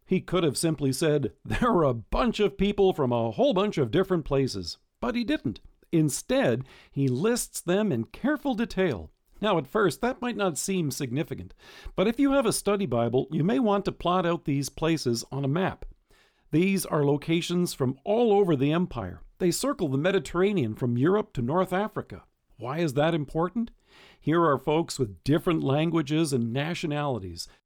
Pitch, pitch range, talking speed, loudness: 165 Hz, 135-190 Hz, 180 wpm, -26 LUFS